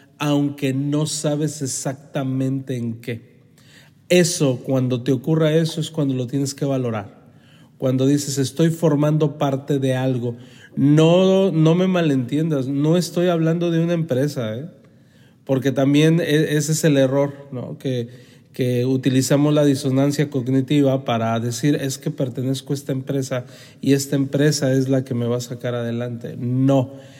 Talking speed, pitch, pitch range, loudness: 150 wpm, 140 Hz, 130-150 Hz, -20 LUFS